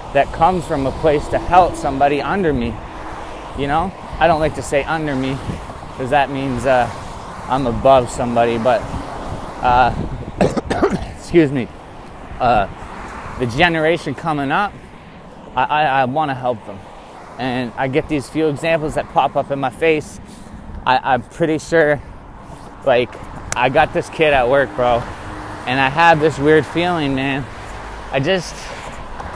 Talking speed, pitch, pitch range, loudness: 155 wpm, 135 Hz, 120-155 Hz, -17 LUFS